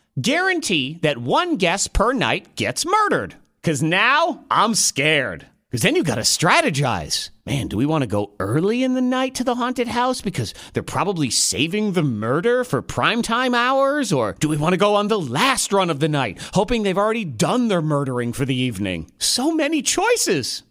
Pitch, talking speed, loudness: 200 Hz, 190 wpm, -19 LUFS